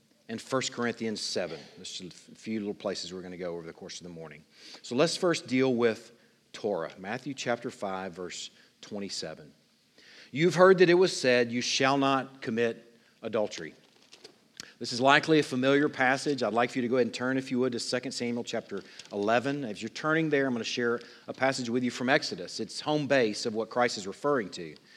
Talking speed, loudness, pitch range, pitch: 210 wpm, -28 LUFS, 115-135 Hz, 125 Hz